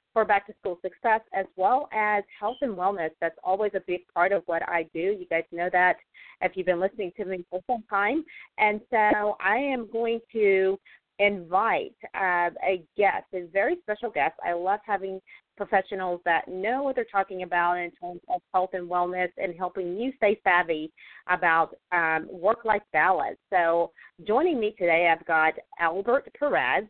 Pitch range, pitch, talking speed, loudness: 175-215 Hz, 190 Hz, 180 wpm, -26 LUFS